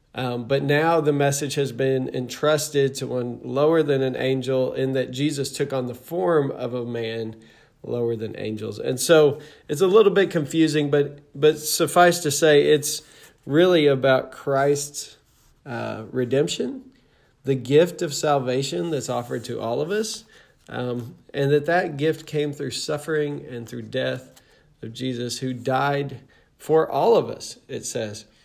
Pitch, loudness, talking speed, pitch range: 140 Hz, -22 LUFS, 160 wpm, 125-150 Hz